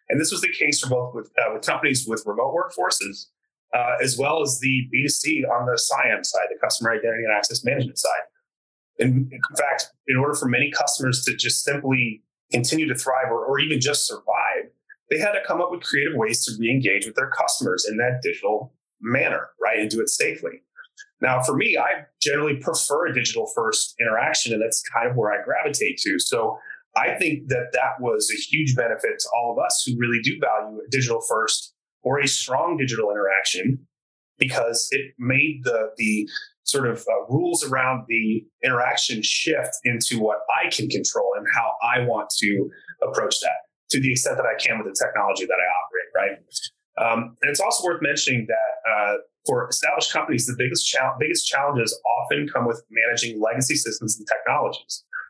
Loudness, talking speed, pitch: -22 LUFS, 195 wpm, 135 Hz